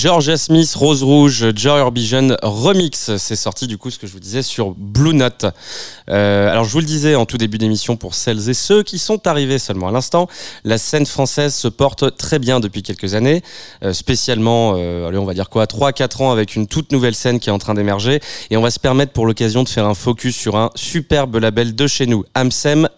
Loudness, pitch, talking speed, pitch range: -15 LUFS, 125 Hz, 230 wpm, 110-145 Hz